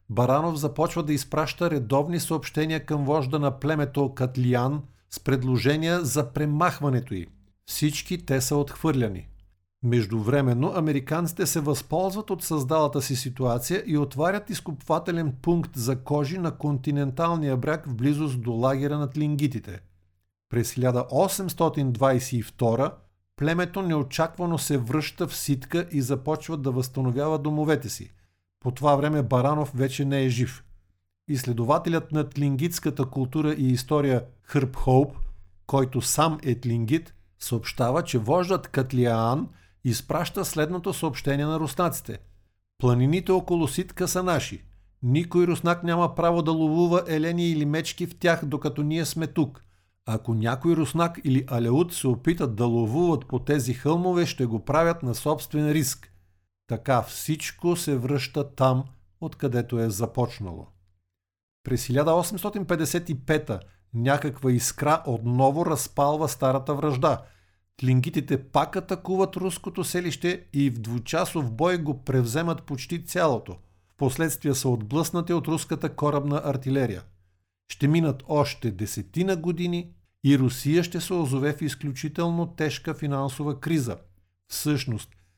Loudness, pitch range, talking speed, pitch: -26 LUFS, 125-160 Hz, 125 wpm, 145 Hz